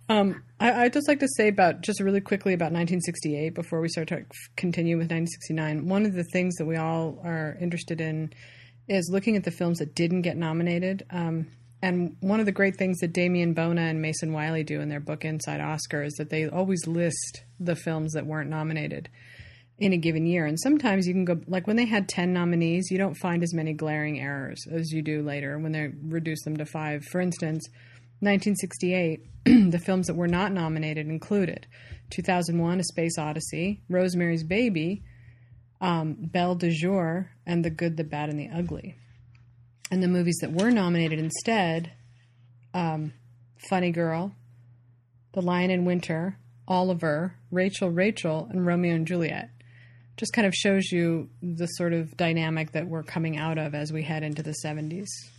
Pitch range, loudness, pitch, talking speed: 155-180 Hz, -27 LUFS, 165 Hz, 180 wpm